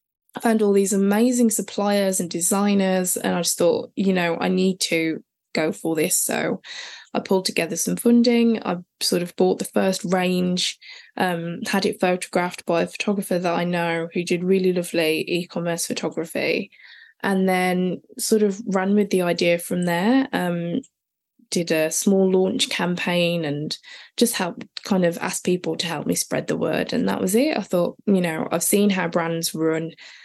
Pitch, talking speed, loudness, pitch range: 185 Hz, 180 wpm, -22 LUFS, 175-210 Hz